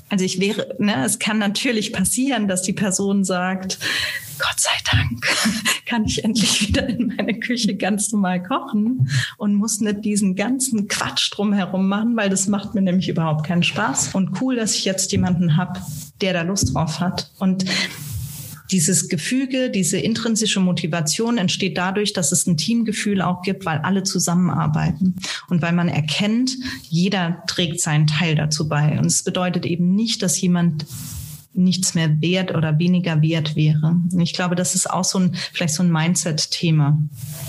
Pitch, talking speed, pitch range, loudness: 185 Hz, 170 wpm, 170-205 Hz, -19 LUFS